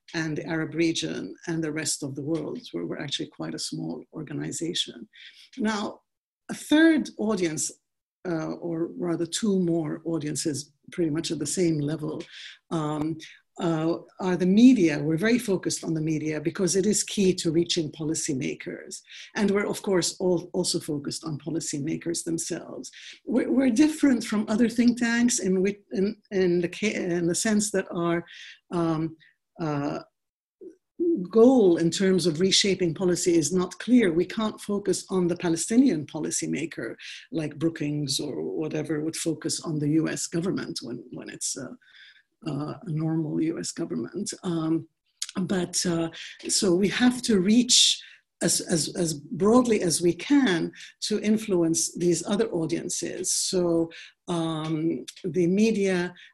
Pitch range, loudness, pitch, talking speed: 160-205 Hz, -25 LUFS, 175 Hz, 145 wpm